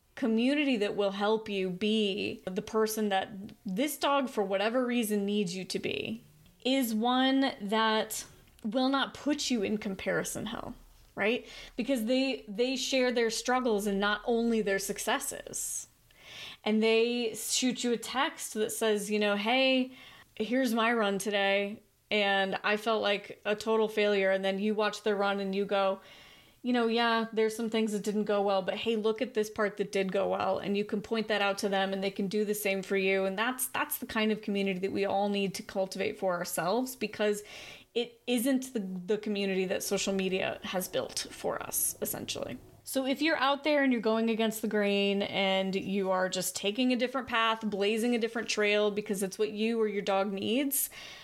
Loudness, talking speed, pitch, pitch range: -30 LUFS, 195 wpm, 215 Hz, 200-235 Hz